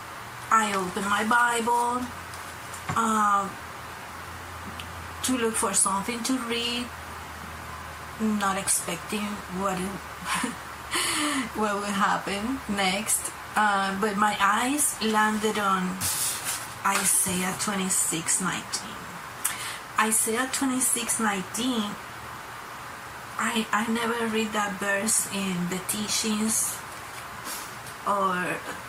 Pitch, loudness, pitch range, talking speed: 205 Hz, -25 LUFS, 190-225 Hz, 80 wpm